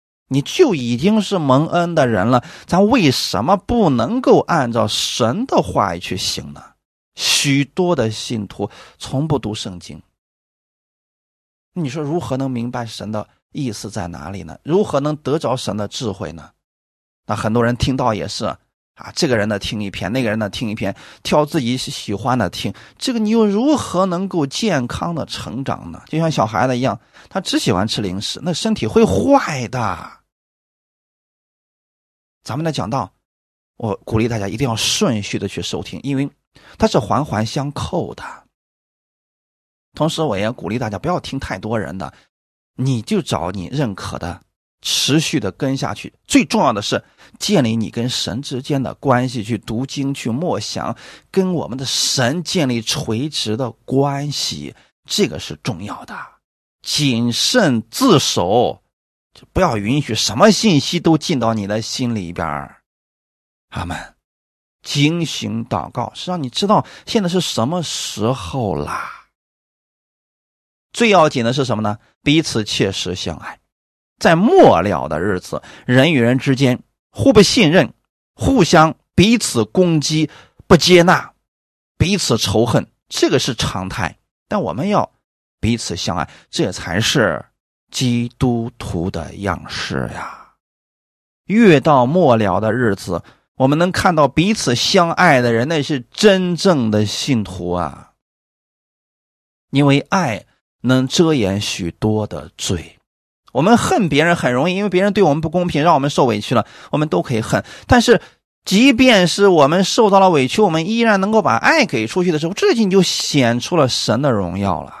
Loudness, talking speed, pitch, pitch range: -17 LUFS, 225 characters per minute, 130 Hz, 105-160 Hz